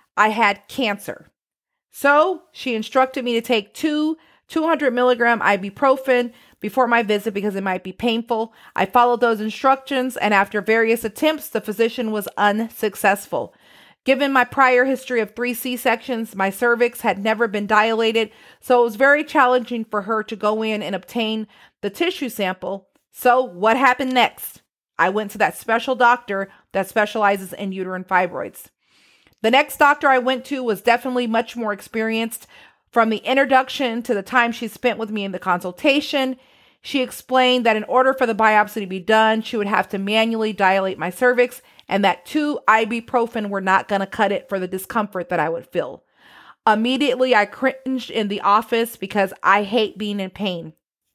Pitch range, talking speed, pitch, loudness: 205-255 Hz, 175 wpm, 225 Hz, -19 LUFS